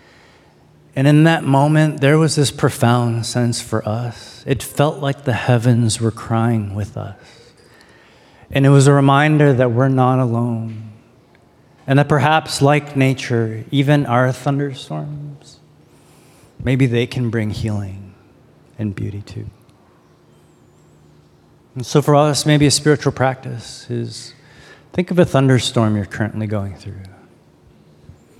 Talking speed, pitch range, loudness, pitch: 130 wpm, 110-140 Hz, -16 LUFS, 125 Hz